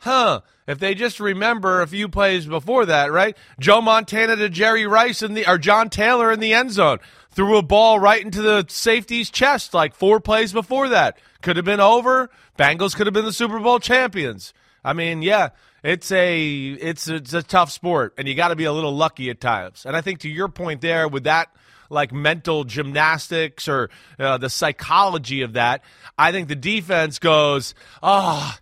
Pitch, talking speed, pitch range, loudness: 180 Hz, 200 wpm, 150-215 Hz, -18 LUFS